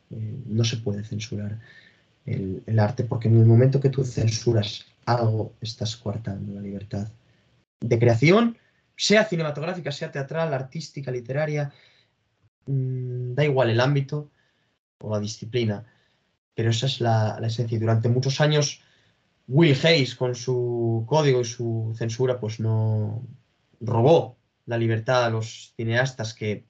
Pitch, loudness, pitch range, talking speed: 120 Hz, -24 LUFS, 110-135 Hz, 140 wpm